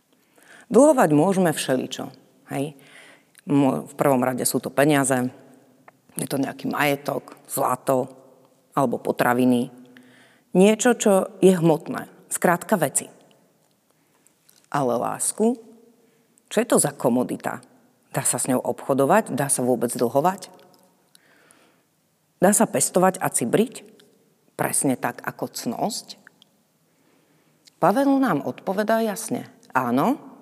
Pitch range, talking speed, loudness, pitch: 135-220 Hz, 105 wpm, -22 LUFS, 180 Hz